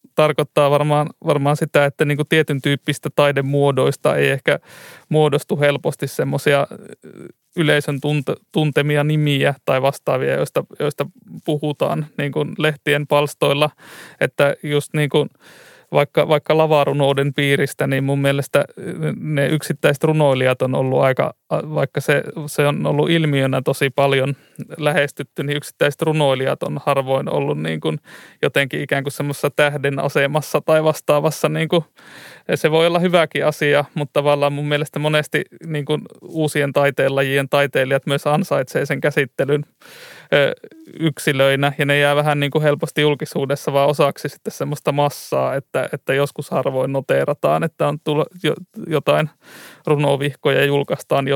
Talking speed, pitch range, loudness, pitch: 135 wpm, 140-155 Hz, -18 LUFS, 145 Hz